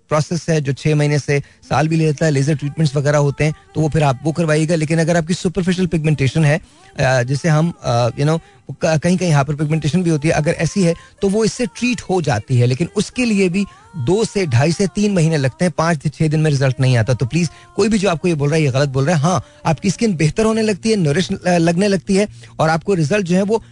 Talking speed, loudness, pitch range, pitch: 255 wpm, -17 LUFS, 150-185 Hz, 160 Hz